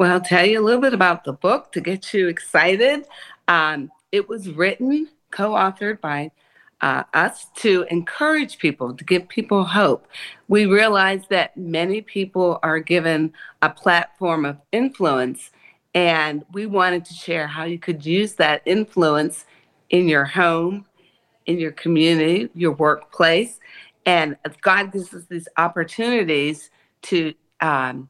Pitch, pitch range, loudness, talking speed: 175 Hz, 160-200 Hz, -19 LUFS, 145 wpm